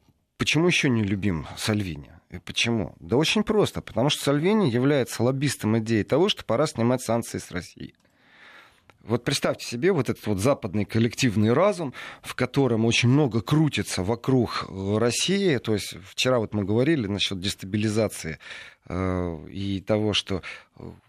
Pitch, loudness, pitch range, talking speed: 115 Hz, -24 LUFS, 100-135 Hz, 140 wpm